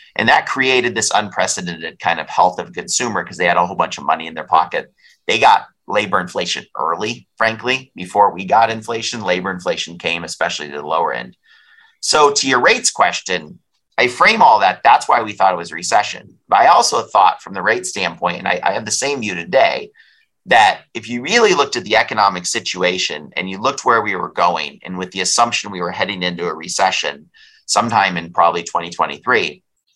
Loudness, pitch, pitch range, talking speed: -16 LUFS, 95 Hz, 90-120 Hz, 205 wpm